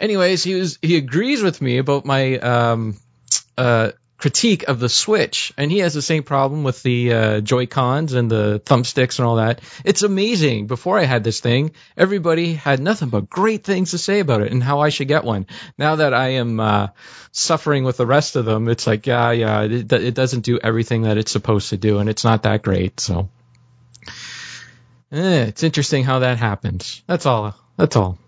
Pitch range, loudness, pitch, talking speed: 115-150 Hz, -18 LUFS, 125 Hz, 205 wpm